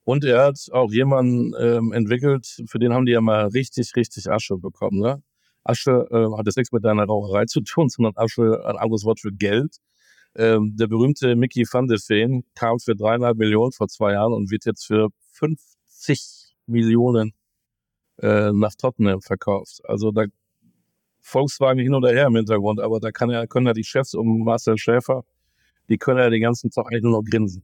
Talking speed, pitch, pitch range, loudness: 190 wpm, 115 Hz, 110-125 Hz, -20 LUFS